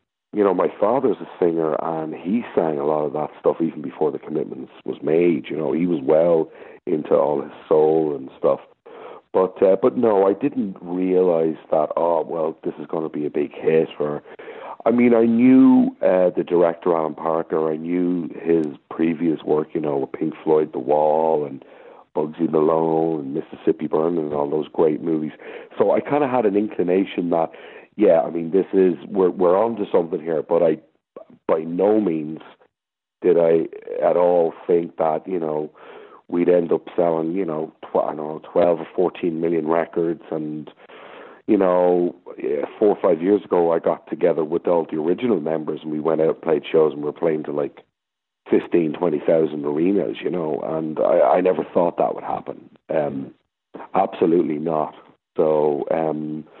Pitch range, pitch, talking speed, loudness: 75-90 Hz, 80 Hz, 190 wpm, -20 LUFS